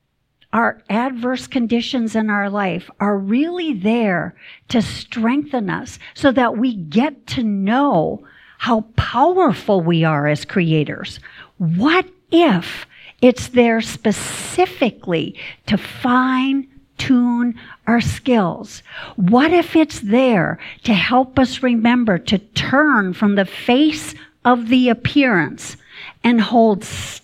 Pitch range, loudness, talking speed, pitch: 205-260 Hz, -17 LUFS, 115 wpm, 235 Hz